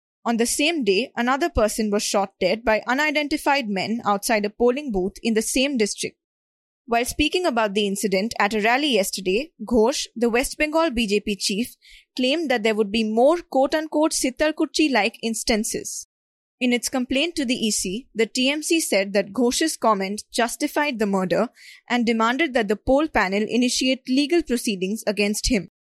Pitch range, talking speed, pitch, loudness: 215-280 Hz, 165 wpm, 235 Hz, -22 LUFS